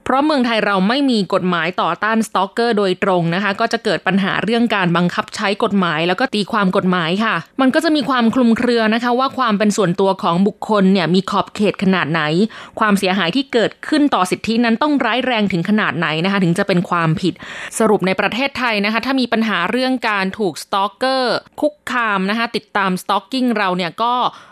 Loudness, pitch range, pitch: -16 LUFS, 190-235 Hz, 210 Hz